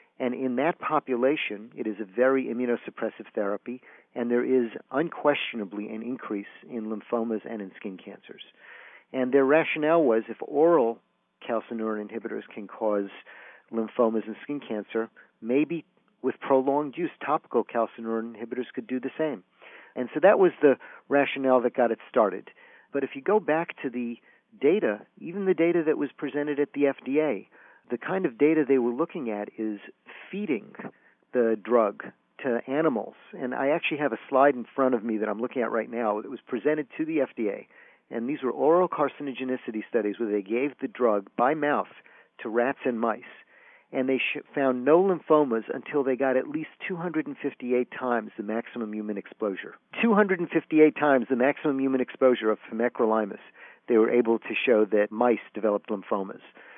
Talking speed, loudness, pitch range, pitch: 170 wpm, -27 LUFS, 115-145 Hz, 125 Hz